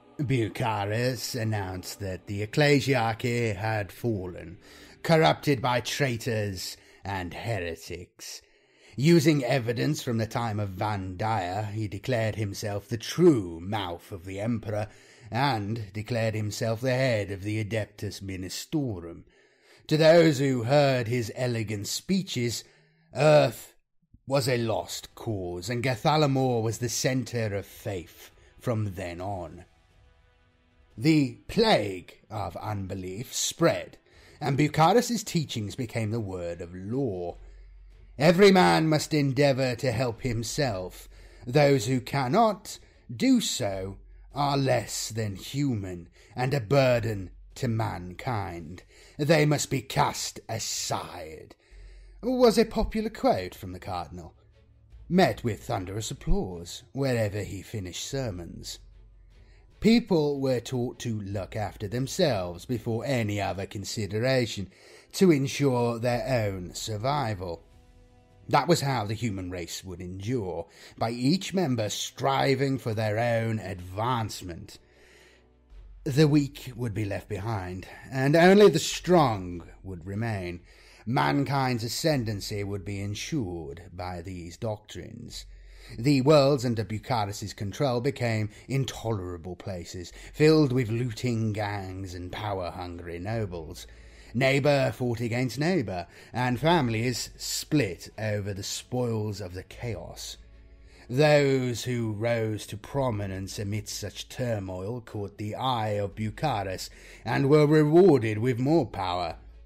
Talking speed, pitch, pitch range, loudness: 115 wpm, 110 Hz, 100-130 Hz, -27 LUFS